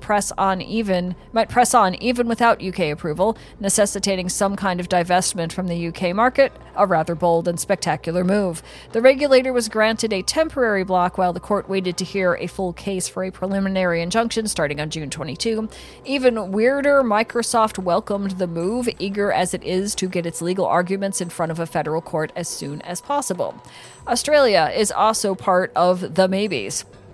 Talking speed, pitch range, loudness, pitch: 180 wpm, 175-220 Hz, -20 LUFS, 190 Hz